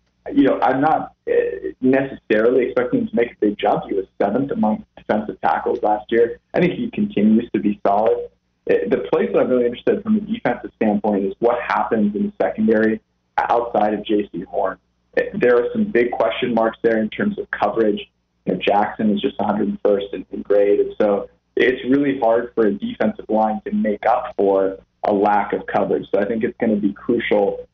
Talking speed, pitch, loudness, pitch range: 200 wpm, 115 Hz, -19 LUFS, 105-175 Hz